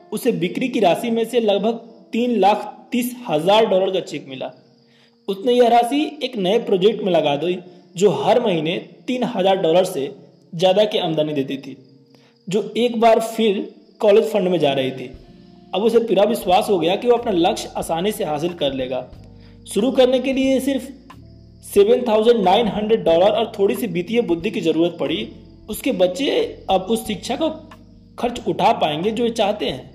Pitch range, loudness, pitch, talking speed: 175-235 Hz, -19 LUFS, 210 Hz, 175 wpm